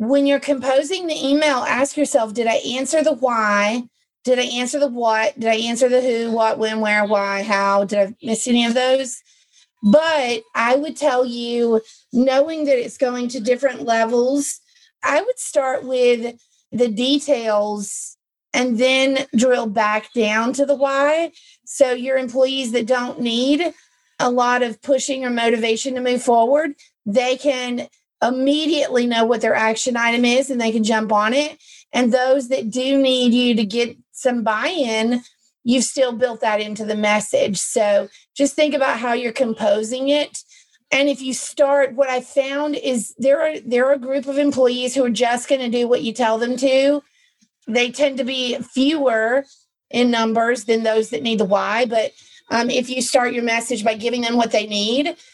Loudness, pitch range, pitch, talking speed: -19 LUFS, 230-275 Hz, 250 Hz, 180 wpm